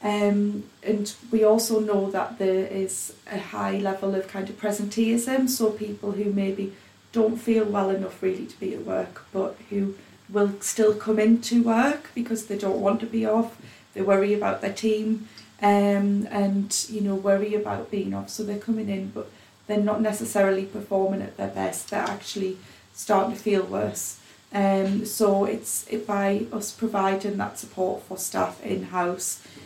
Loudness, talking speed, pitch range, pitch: -25 LUFS, 170 wpm, 195-215 Hz, 205 Hz